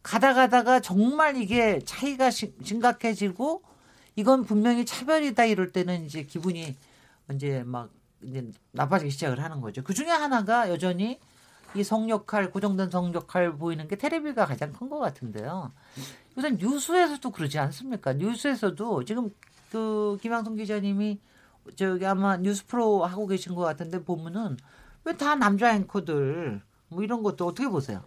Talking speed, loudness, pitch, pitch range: 325 characters per minute, -27 LUFS, 205 Hz, 170-240 Hz